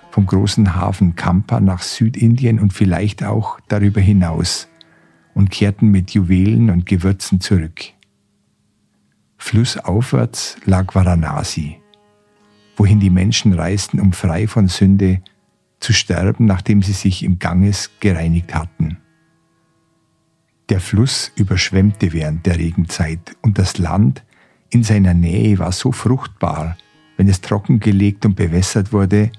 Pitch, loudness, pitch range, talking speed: 100 Hz, -16 LUFS, 90-105 Hz, 120 wpm